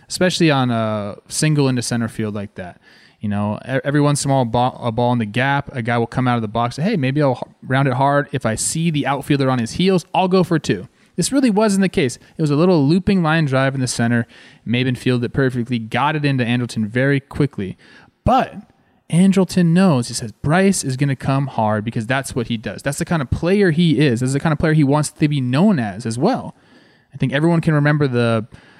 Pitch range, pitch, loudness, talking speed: 120-155 Hz, 135 Hz, -18 LUFS, 245 wpm